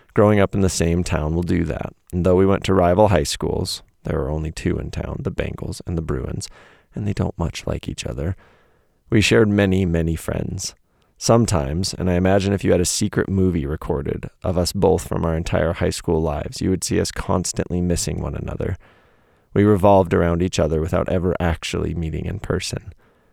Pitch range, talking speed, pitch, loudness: 80-95 Hz, 205 wpm, 90 Hz, -21 LUFS